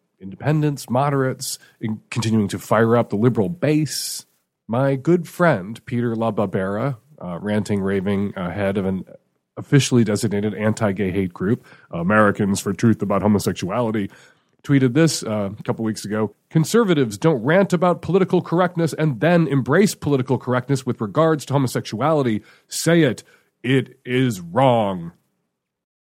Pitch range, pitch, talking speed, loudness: 105-150 Hz, 120 Hz, 135 wpm, -20 LUFS